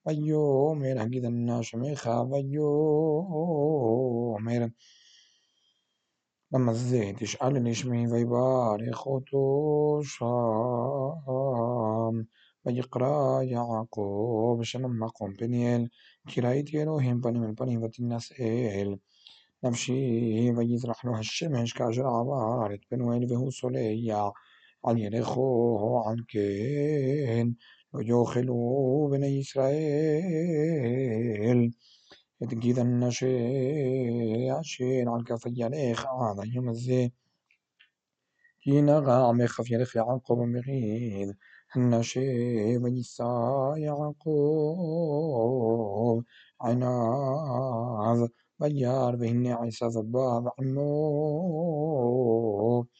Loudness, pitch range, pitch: -28 LUFS, 115-135 Hz, 120 Hz